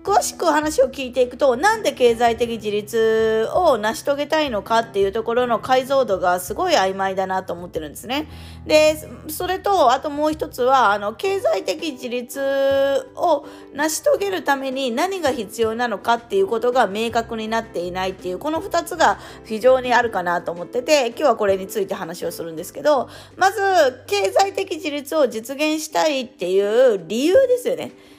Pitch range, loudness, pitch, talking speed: 215-305 Hz, -20 LUFS, 255 Hz, 360 characters per minute